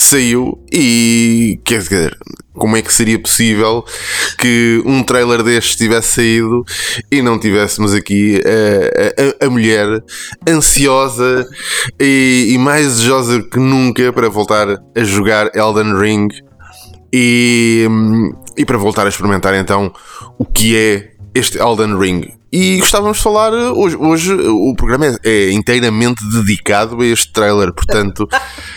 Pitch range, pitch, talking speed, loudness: 105-125 Hz, 115 Hz, 135 wpm, -11 LUFS